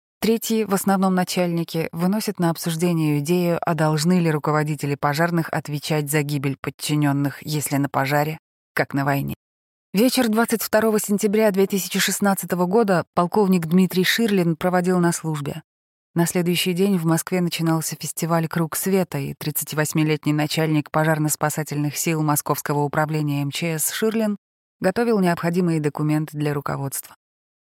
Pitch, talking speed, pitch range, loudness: 165 Hz, 125 wpm, 150-185 Hz, -21 LUFS